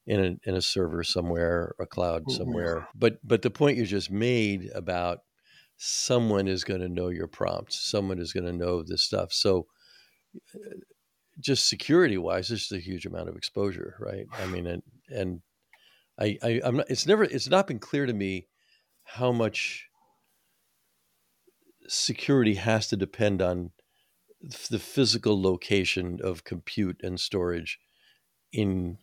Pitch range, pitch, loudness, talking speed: 90-115 Hz, 95 Hz, -28 LUFS, 155 wpm